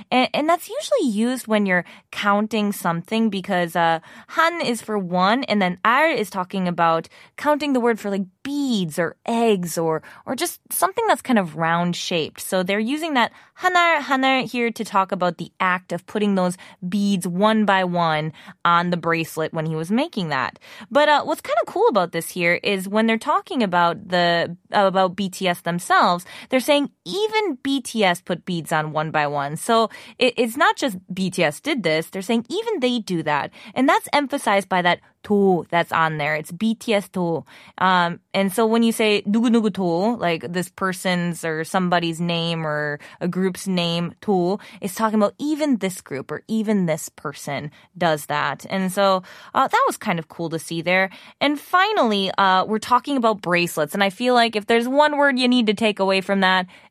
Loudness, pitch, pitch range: -21 LUFS, 195 Hz, 175-235 Hz